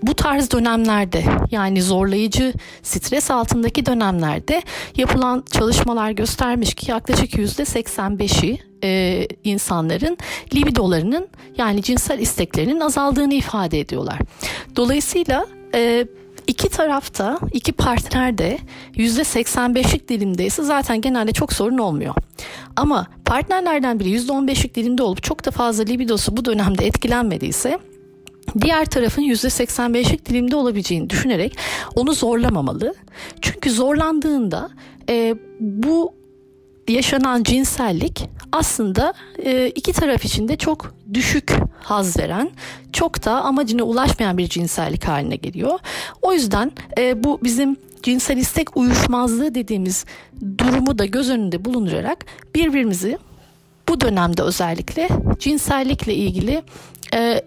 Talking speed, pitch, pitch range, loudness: 110 wpm, 245 Hz, 205-275 Hz, -19 LUFS